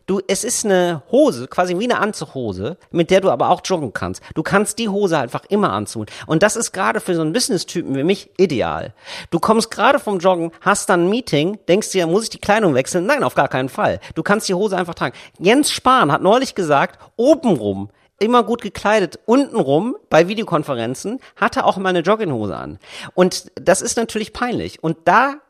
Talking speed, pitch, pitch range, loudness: 205 wpm, 185 Hz, 160-215 Hz, -18 LUFS